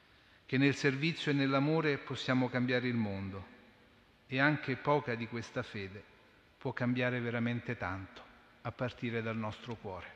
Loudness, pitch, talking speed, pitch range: -34 LUFS, 125 Hz, 140 wpm, 115-130 Hz